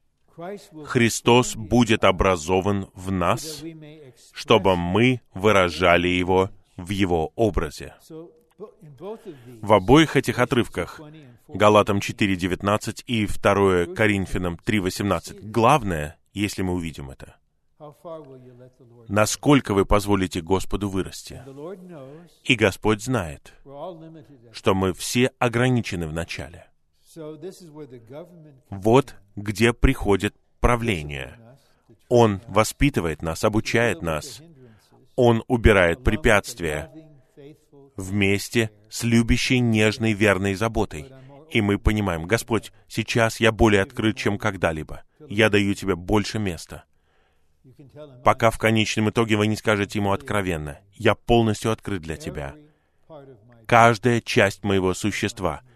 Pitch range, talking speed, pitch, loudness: 95-125 Hz, 100 wpm, 110 Hz, -22 LUFS